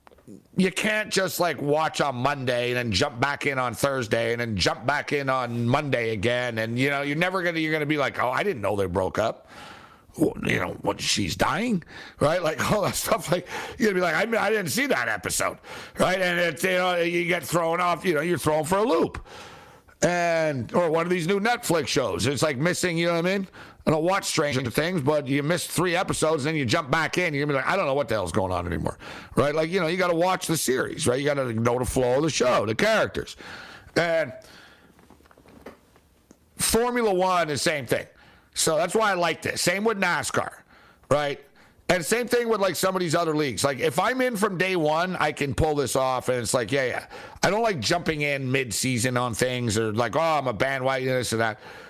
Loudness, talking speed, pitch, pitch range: -24 LUFS, 235 wpm, 160 Hz, 130-180 Hz